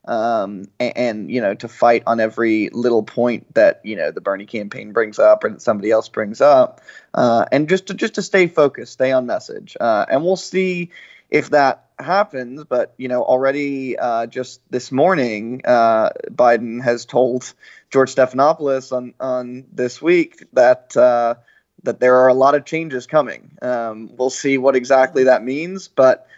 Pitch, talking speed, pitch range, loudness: 130 Hz, 175 wpm, 120-160 Hz, -17 LUFS